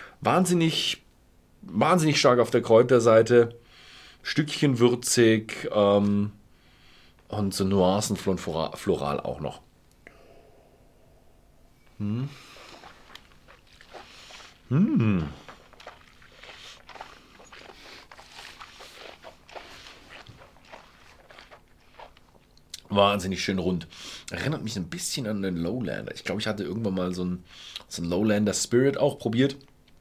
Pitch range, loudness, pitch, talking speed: 95-125 Hz, -25 LUFS, 105 Hz, 80 wpm